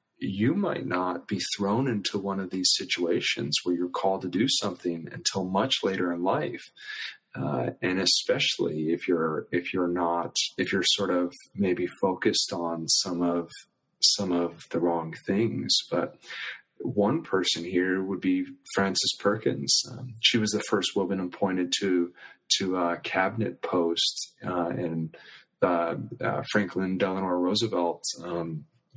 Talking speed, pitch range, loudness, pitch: 150 wpm, 85-95 Hz, -27 LUFS, 90 Hz